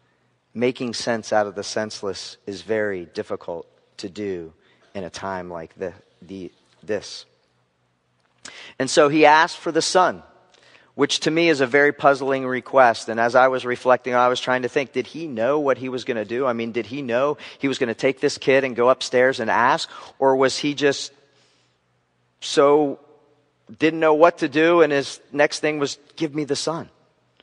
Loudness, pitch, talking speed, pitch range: -20 LUFS, 130 Hz, 195 wpm, 115-145 Hz